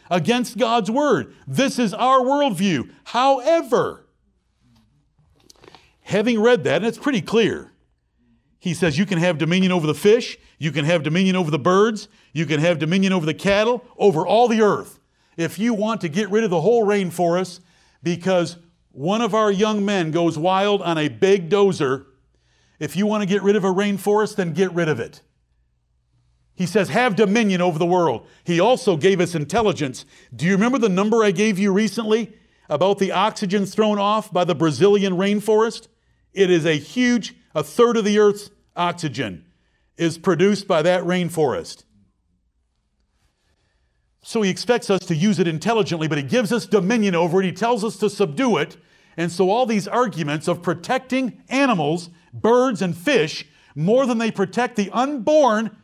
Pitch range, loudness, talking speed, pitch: 165-220 Hz, -20 LUFS, 175 wpm, 195 Hz